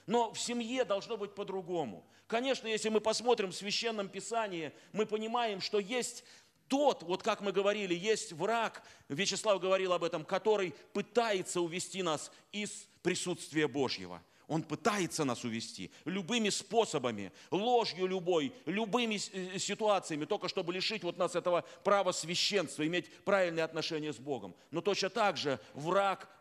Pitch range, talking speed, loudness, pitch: 165-215 Hz, 145 wpm, -34 LUFS, 190 Hz